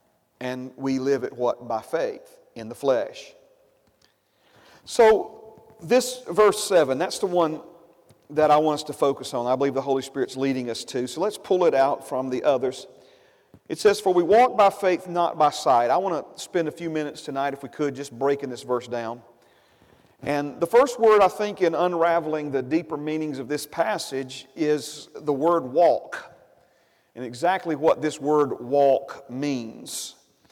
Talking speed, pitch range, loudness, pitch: 180 wpm, 135-190 Hz, -23 LUFS, 150 Hz